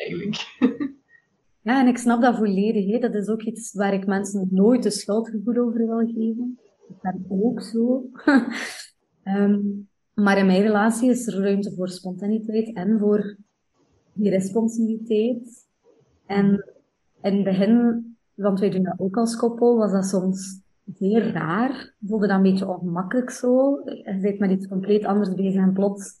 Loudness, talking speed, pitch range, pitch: -22 LUFS, 160 wpm, 195-235 Hz, 210 Hz